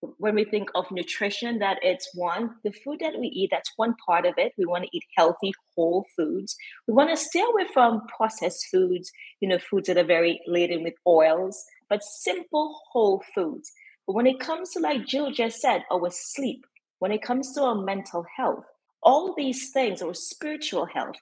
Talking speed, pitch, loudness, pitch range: 200 wpm, 215 Hz, -25 LUFS, 180-280 Hz